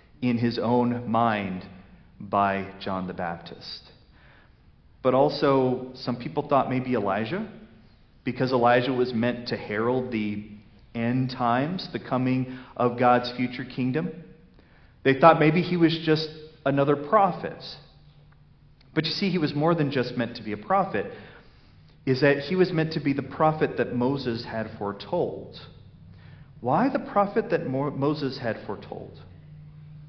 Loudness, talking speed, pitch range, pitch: -25 LUFS, 140 wpm, 120-150 Hz, 130 Hz